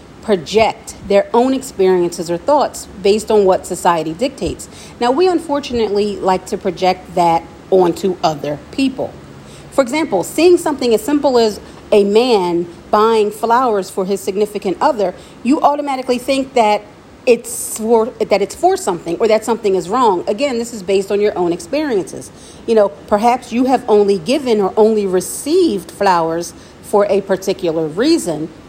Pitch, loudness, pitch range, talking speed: 210 Hz, -15 LUFS, 190-245 Hz, 155 wpm